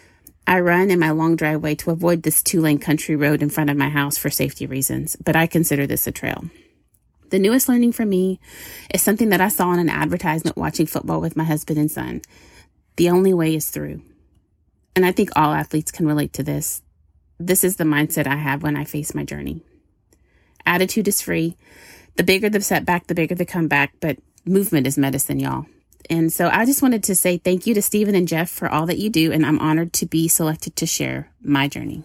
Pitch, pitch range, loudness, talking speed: 160 Hz, 145-180 Hz, -19 LUFS, 215 wpm